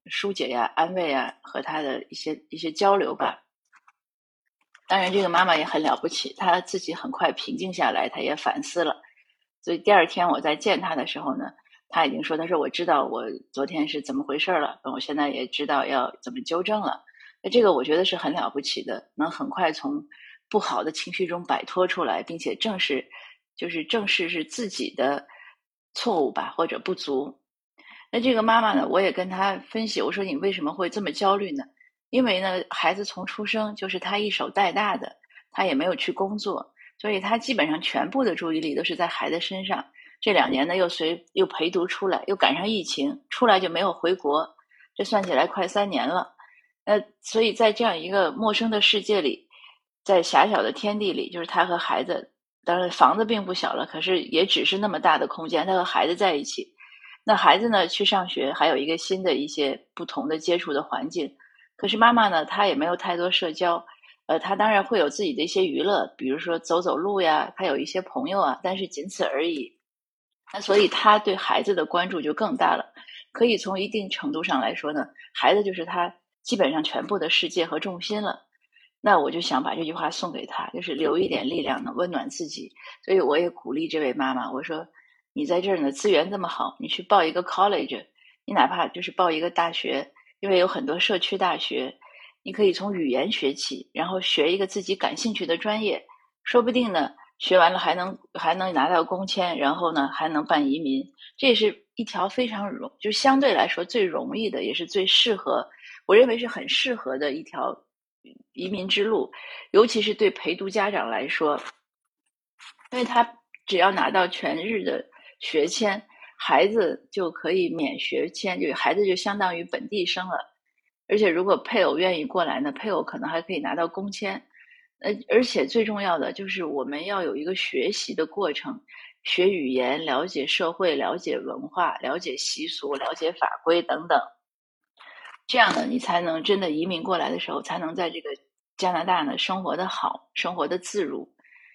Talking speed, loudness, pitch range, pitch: 290 characters per minute, -24 LUFS, 175-265 Hz, 200 Hz